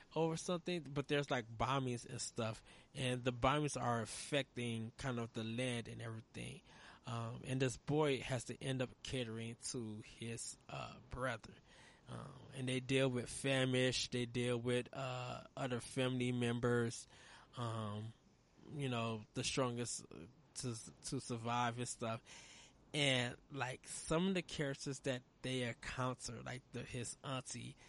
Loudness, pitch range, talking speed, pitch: -41 LUFS, 115-135 Hz, 145 wpm, 125 Hz